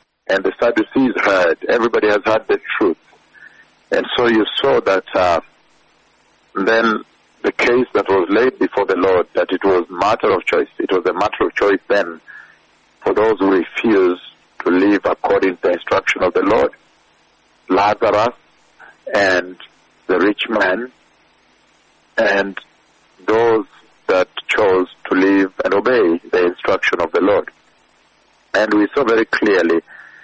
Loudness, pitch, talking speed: -16 LUFS, 105 Hz, 145 wpm